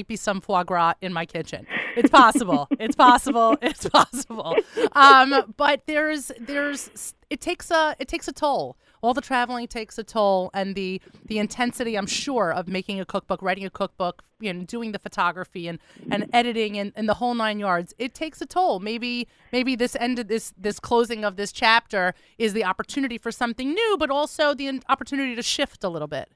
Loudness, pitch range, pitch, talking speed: -22 LUFS, 200-270 Hz, 235 Hz, 200 wpm